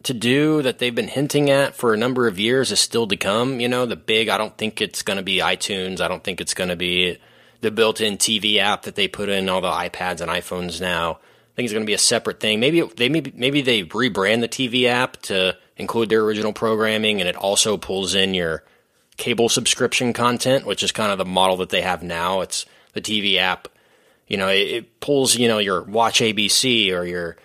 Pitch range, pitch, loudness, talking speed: 95-125 Hz, 110 Hz, -19 LUFS, 235 wpm